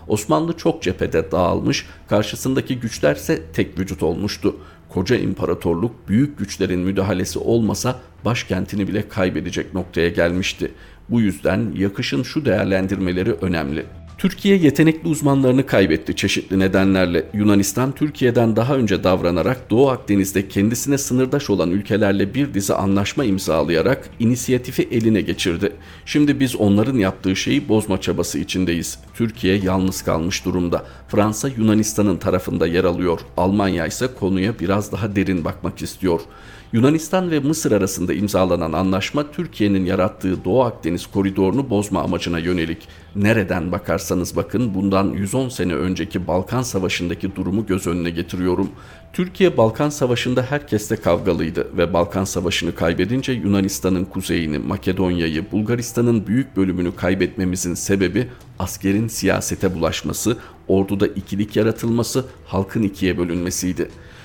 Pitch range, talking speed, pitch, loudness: 90-115 Hz, 120 wpm, 100 Hz, -20 LUFS